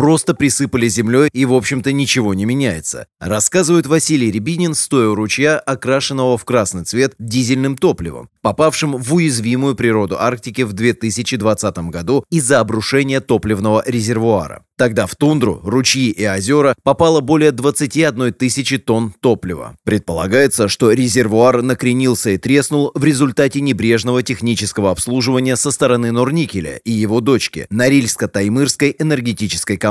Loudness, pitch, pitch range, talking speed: -15 LUFS, 125 Hz, 110-140 Hz, 130 wpm